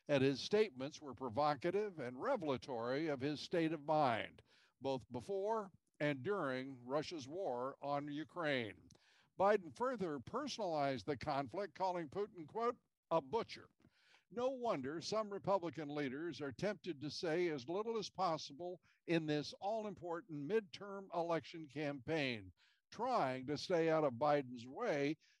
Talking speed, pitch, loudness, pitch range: 135 wpm, 160 Hz, -41 LUFS, 145-195 Hz